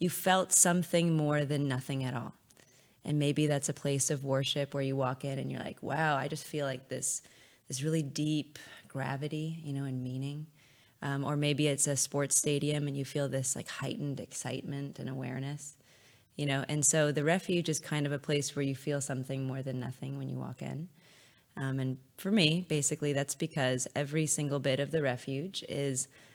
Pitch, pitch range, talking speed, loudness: 140 Hz, 135-150 Hz, 200 wpm, -32 LUFS